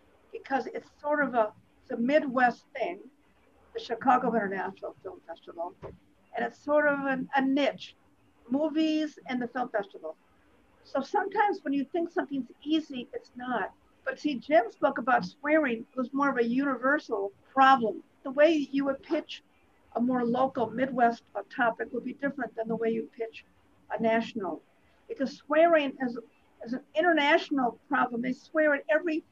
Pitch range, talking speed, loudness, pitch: 235-295 Hz, 160 wpm, -29 LUFS, 265 Hz